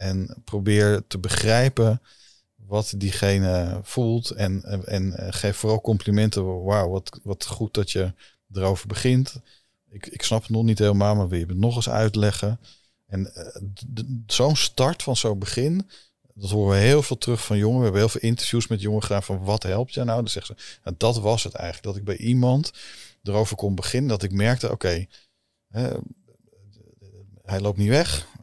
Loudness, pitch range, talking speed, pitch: -23 LUFS, 100-115 Hz, 195 wpm, 105 Hz